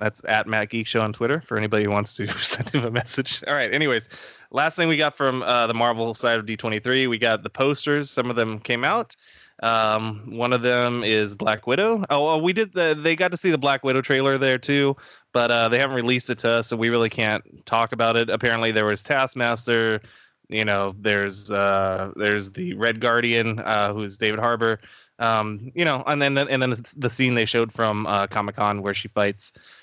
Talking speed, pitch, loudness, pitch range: 220 wpm, 115 Hz, -22 LUFS, 110-130 Hz